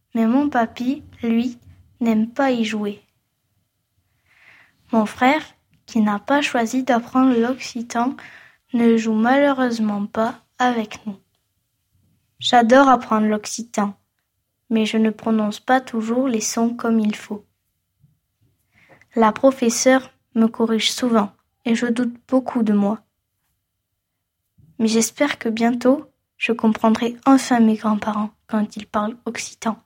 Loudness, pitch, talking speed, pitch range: -20 LUFS, 225 Hz, 120 wpm, 205-245 Hz